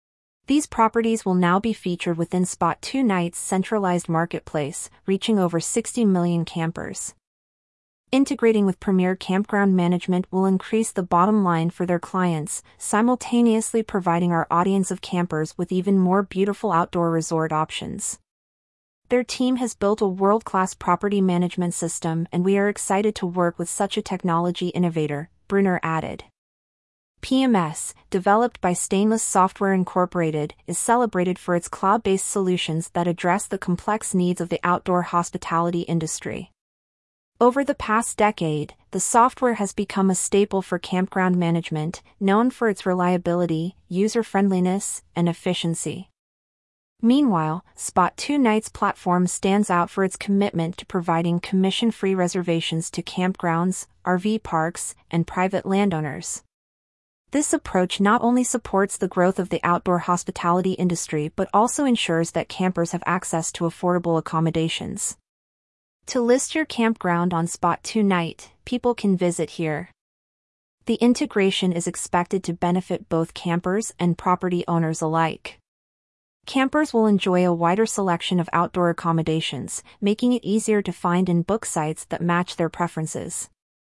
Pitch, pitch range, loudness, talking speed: 185 Hz, 170-205 Hz, -22 LUFS, 135 wpm